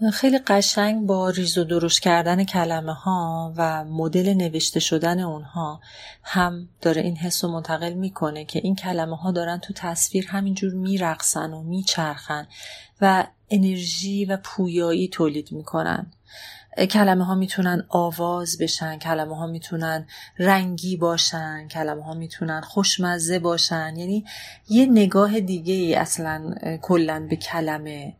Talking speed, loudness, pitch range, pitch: 130 wpm, -22 LUFS, 160-190 Hz, 175 Hz